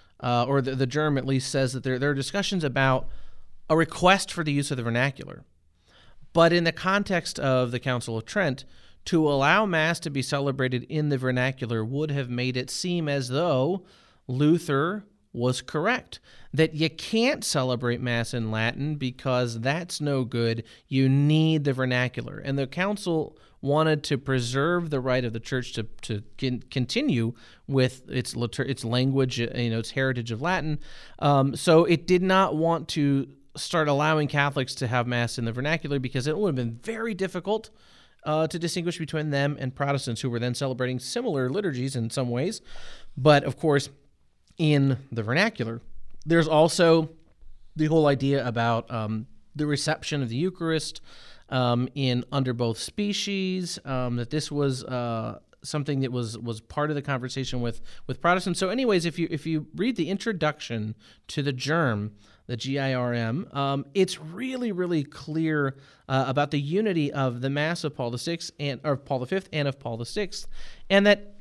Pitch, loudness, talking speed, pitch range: 140 Hz, -26 LUFS, 180 wpm, 125-160 Hz